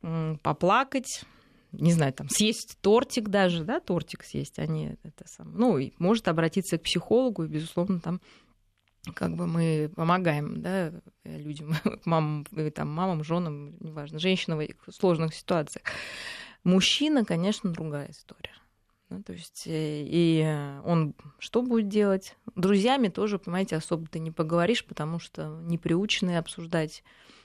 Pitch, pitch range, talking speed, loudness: 170 Hz, 155-195 Hz, 135 wpm, -28 LUFS